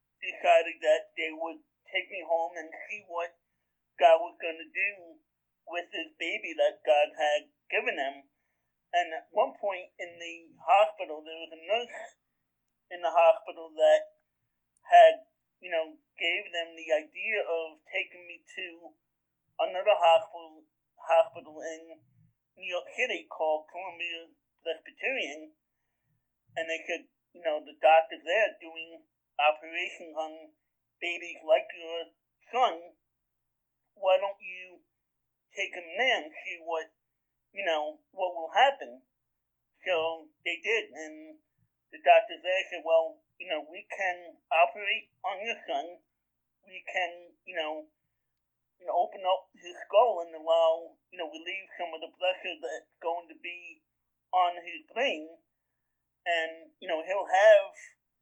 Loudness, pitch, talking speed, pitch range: -29 LUFS, 165 Hz, 140 wpm, 160-185 Hz